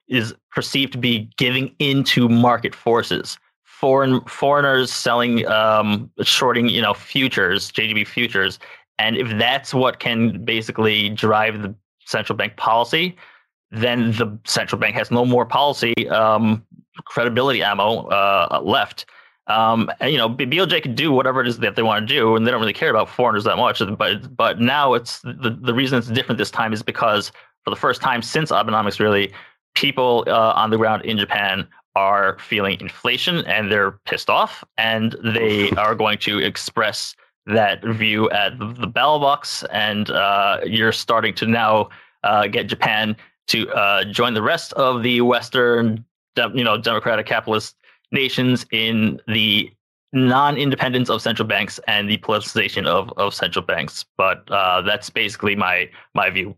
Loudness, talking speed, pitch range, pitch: -18 LUFS, 165 wpm, 110-125 Hz, 115 Hz